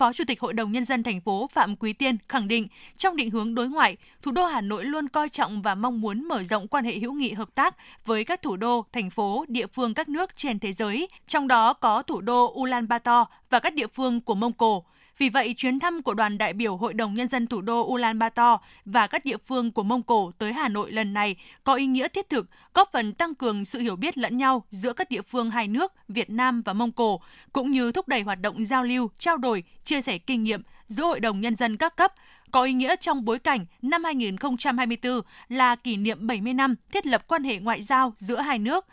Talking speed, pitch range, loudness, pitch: 245 wpm, 225-270 Hz, -25 LUFS, 240 Hz